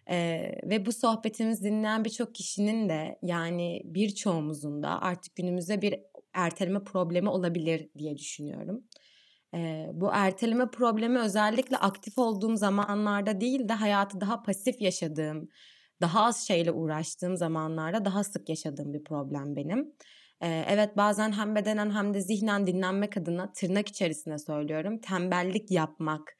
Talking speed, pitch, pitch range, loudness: 135 wpm, 195 Hz, 170-215 Hz, -30 LUFS